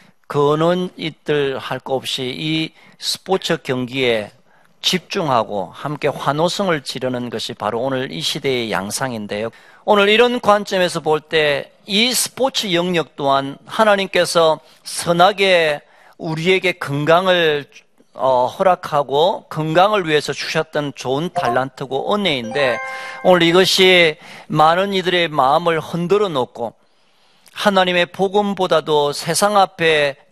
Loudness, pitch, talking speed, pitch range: -17 LUFS, 160 Hz, 255 characters per minute, 140-185 Hz